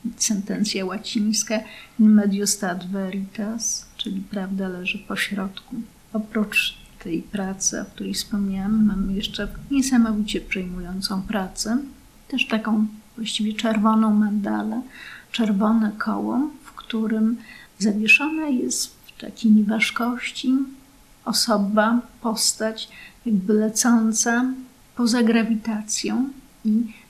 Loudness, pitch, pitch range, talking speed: -22 LUFS, 220 Hz, 205-235 Hz, 90 wpm